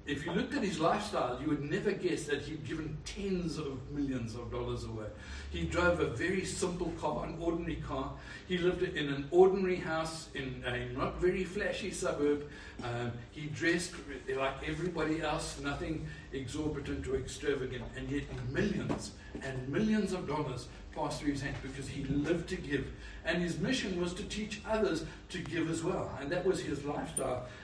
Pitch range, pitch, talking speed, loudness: 135-180 Hz, 150 Hz, 180 wpm, -35 LUFS